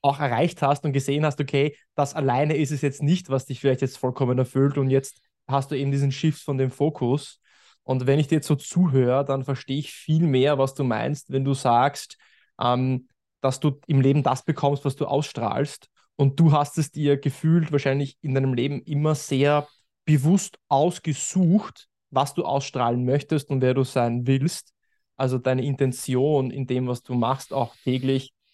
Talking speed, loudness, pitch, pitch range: 190 wpm, -23 LUFS, 140 Hz, 130-150 Hz